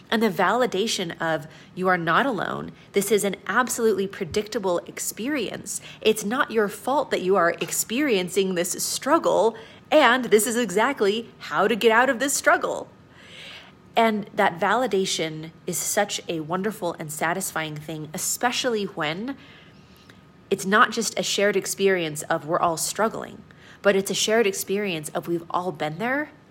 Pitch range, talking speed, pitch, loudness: 175-225 Hz, 150 wpm, 200 Hz, -23 LUFS